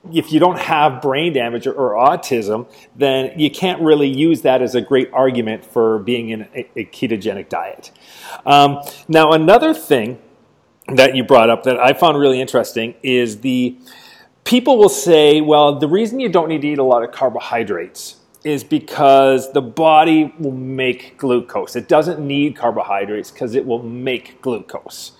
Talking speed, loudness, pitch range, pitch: 170 wpm, -15 LUFS, 125-155 Hz, 135 Hz